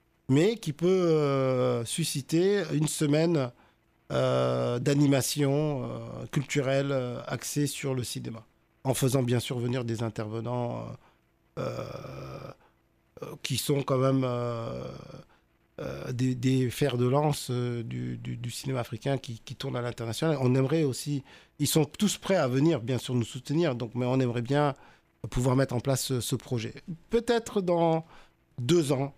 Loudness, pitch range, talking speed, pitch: -28 LUFS, 120-150 Hz, 155 wpm, 135 Hz